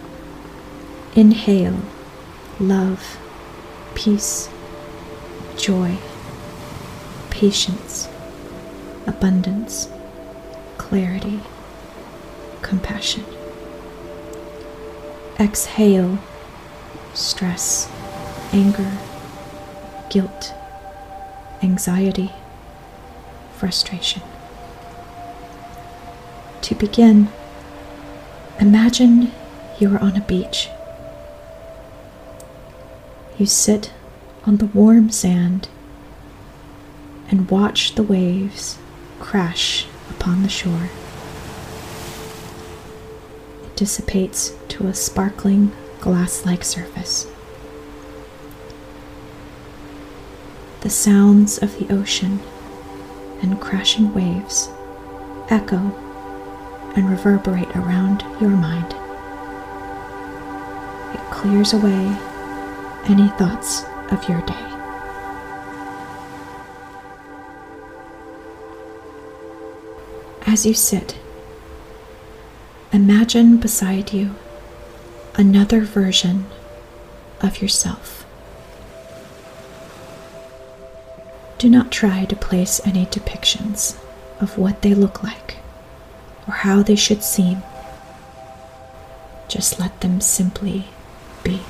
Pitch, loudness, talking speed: 165 Hz, -18 LUFS, 65 wpm